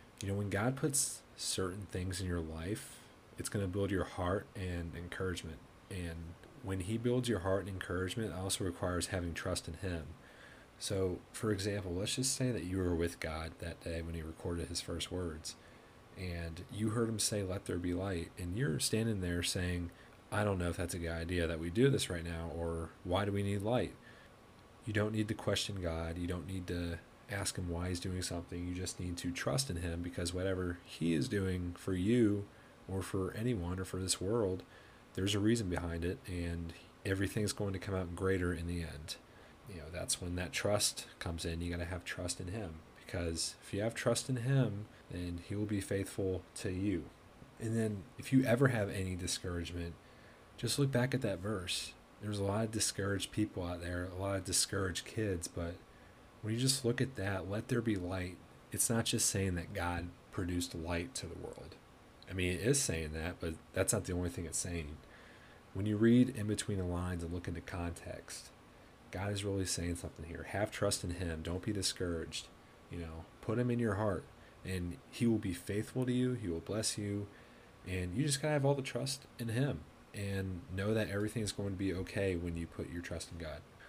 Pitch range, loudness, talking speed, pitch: 85-110 Hz, -37 LUFS, 215 wpm, 95 Hz